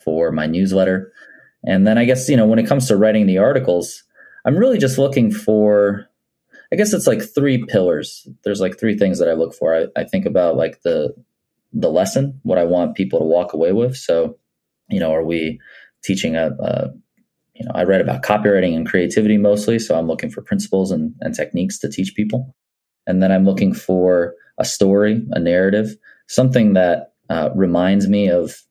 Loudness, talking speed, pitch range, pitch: -17 LUFS, 195 wpm, 90-110 Hz, 100 Hz